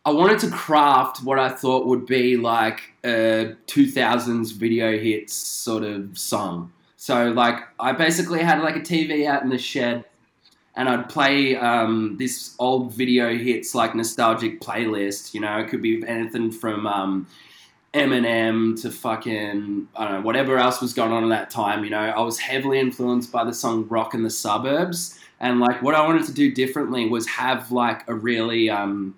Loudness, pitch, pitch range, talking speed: -22 LUFS, 120 Hz, 110-130 Hz, 185 wpm